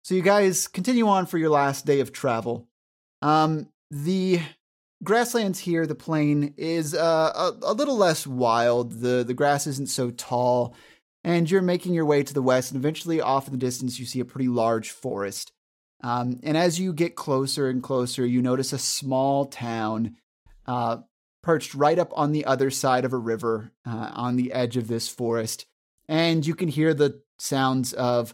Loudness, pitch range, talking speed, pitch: -24 LUFS, 125-160 Hz, 185 wpm, 135 Hz